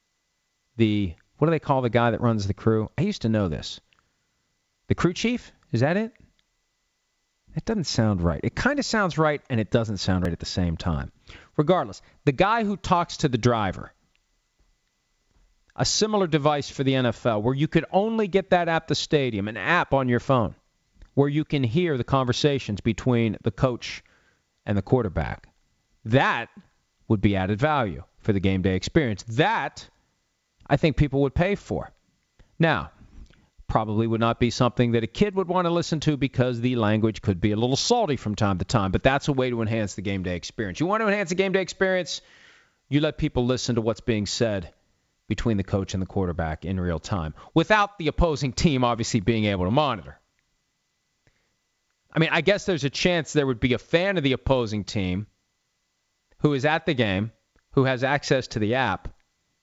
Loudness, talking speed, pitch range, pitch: -24 LUFS, 195 wpm, 105-155 Hz, 125 Hz